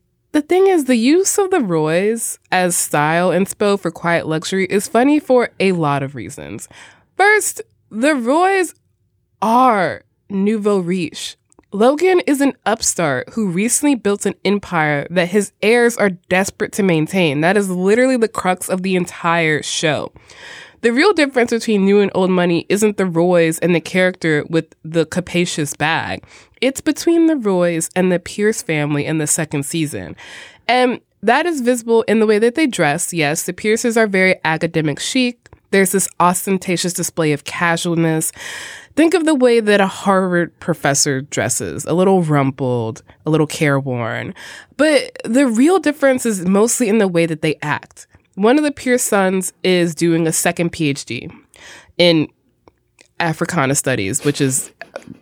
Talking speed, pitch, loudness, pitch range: 160 wpm, 185 Hz, -16 LUFS, 165-235 Hz